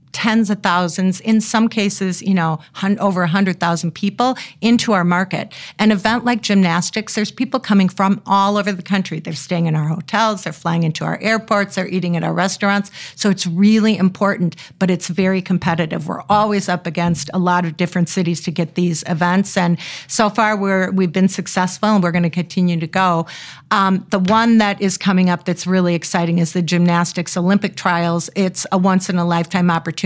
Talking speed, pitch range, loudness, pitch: 195 wpm, 175-200 Hz, -17 LUFS, 185 Hz